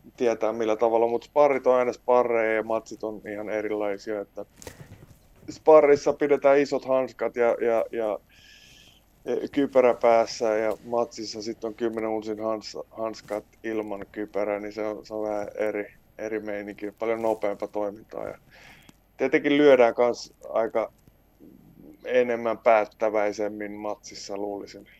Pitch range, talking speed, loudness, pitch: 105-120 Hz, 130 wpm, -25 LUFS, 110 Hz